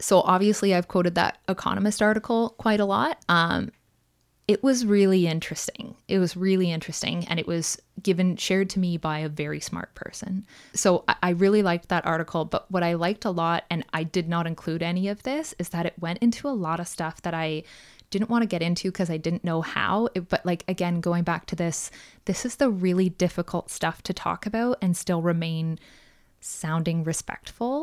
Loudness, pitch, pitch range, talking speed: -25 LUFS, 180 Hz, 170-195 Hz, 205 wpm